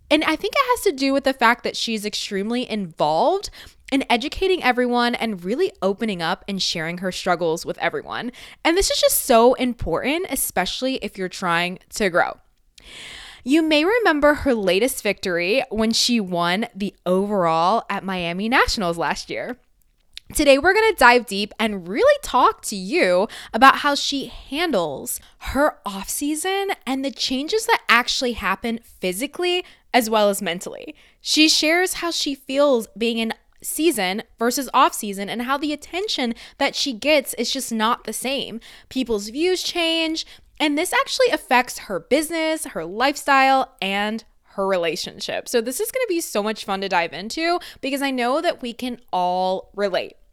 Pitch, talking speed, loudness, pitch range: 245 Hz, 170 wpm, -20 LUFS, 205-295 Hz